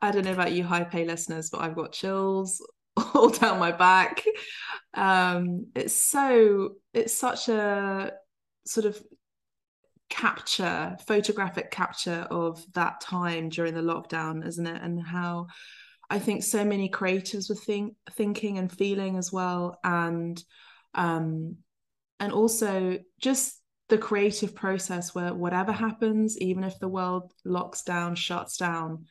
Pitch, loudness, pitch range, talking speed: 185 Hz, -27 LUFS, 175-210 Hz, 140 wpm